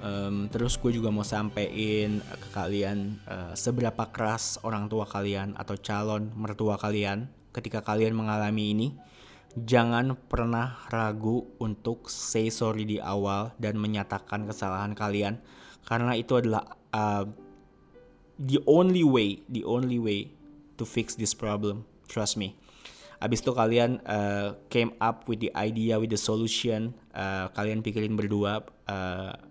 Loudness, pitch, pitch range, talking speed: -29 LUFS, 110 Hz, 100-115 Hz, 135 wpm